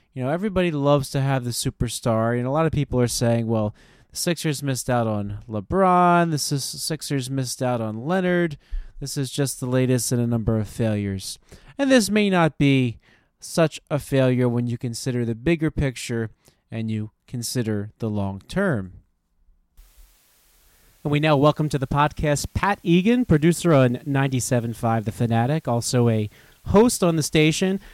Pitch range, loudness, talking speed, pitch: 115-155 Hz, -22 LUFS, 170 wpm, 130 Hz